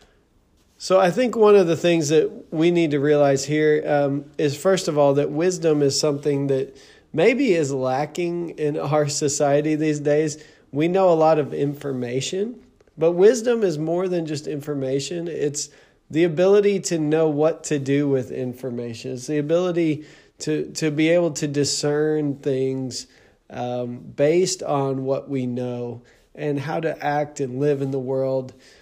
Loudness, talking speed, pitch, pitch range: -21 LUFS, 165 wpm, 150 Hz, 140-165 Hz